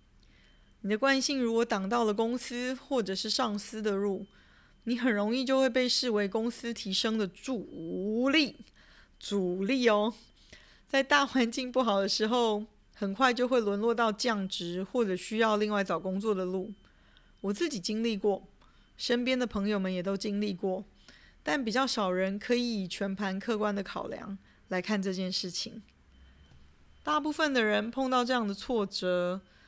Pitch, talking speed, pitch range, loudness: 215 Hz, 235 characters per minute, 195-245 Hz, -30 LUFS